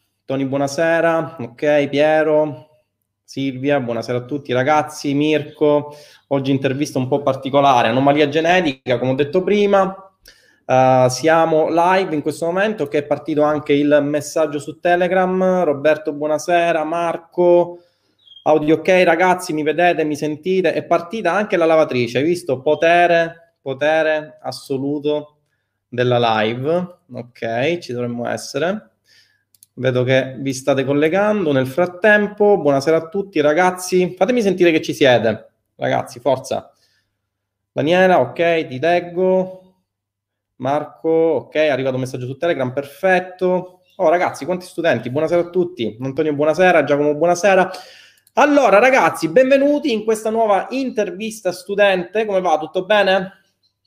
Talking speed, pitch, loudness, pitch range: 130 wpm, 155 Hz, -17 LUFS, 135-180 Hz